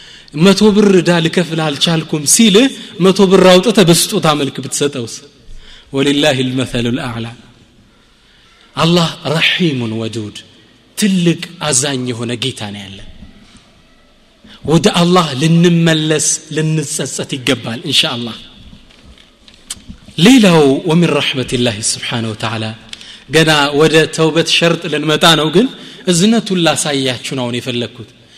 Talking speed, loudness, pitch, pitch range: 95 wpm, -12 LUFS, 150 Hz, 125-170 Hz